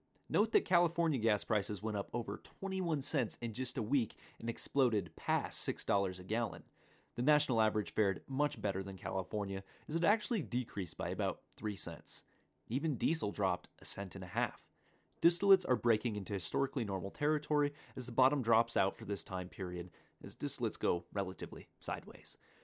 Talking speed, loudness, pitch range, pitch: 170 wpm, -36 LUFS, 100-145 Hz, 115 Hz